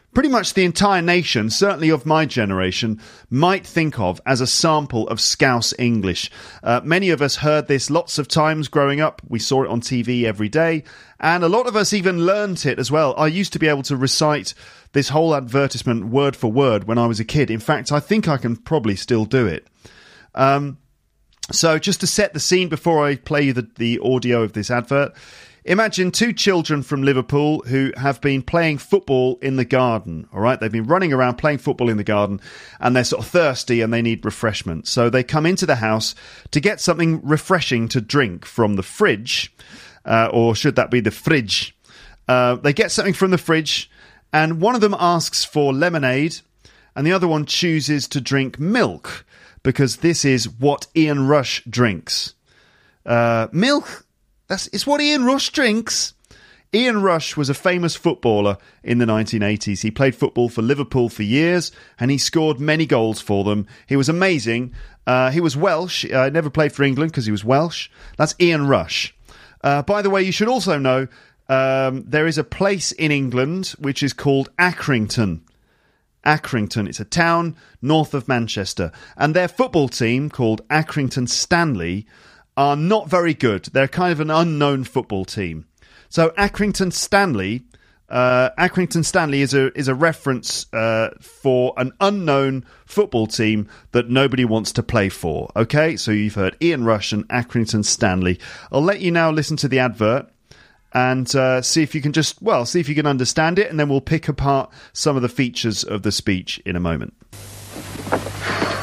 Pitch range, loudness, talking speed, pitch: 115-160 Hz, -19 LUFS, 190 wpm, 140 Hz